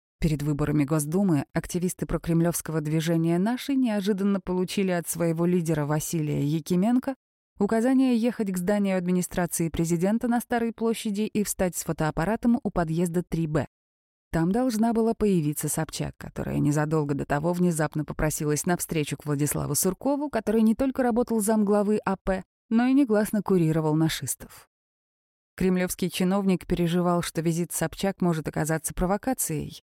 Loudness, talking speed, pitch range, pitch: -26 LUFS, 130 wpm, 160-210 Hz, 180 Hz